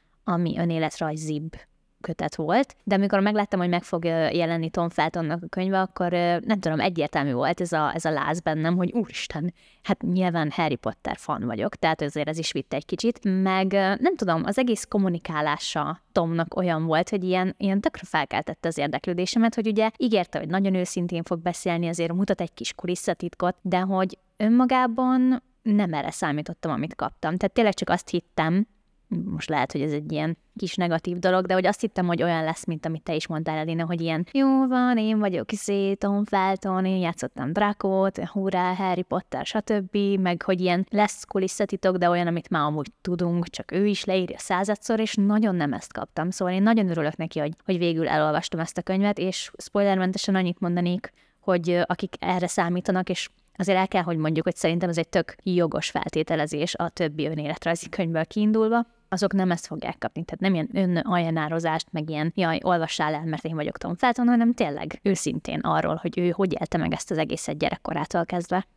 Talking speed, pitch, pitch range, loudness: 185 wpm, 180 Hz, 165-195 Hz, -25 LUFS